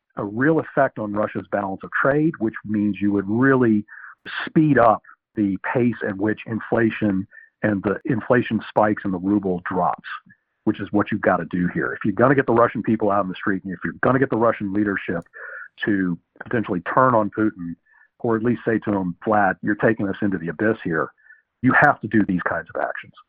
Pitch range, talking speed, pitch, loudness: 100-115 Hz, 210 wpm, 105 Hz, -21 LUFS